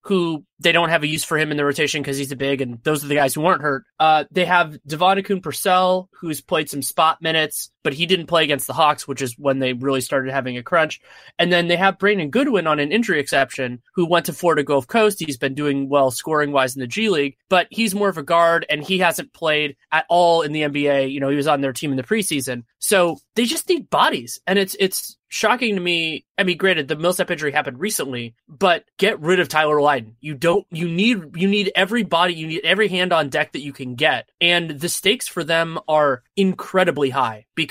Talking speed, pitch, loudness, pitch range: 240 wpm, 155 Hz, -19 LUFS, 140-180 Hz